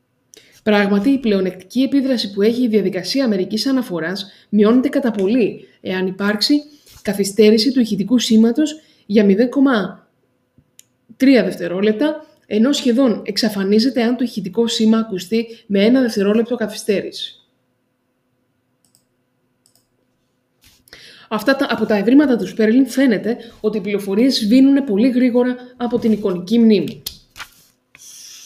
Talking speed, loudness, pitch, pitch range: 110 wpm, -16 LUFS, 220 Hz, 195-250 Hz